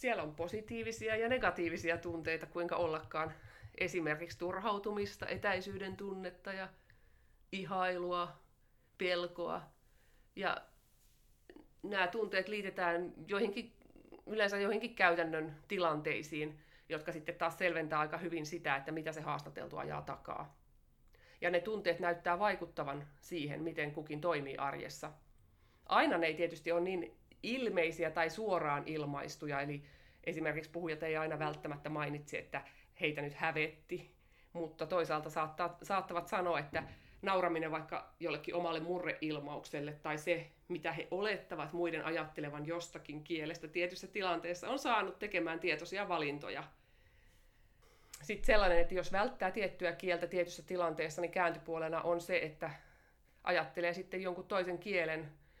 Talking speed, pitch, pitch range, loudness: 120 wpm, 170 Hz, 155-185 Hz, -38 LUFS